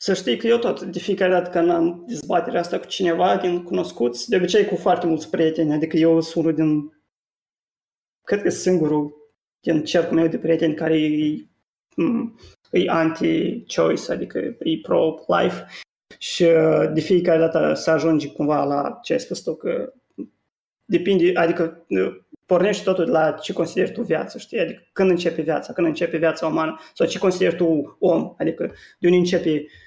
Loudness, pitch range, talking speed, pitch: -21 LUFS, 160-180 Hz, 165 wpm, 165 Hz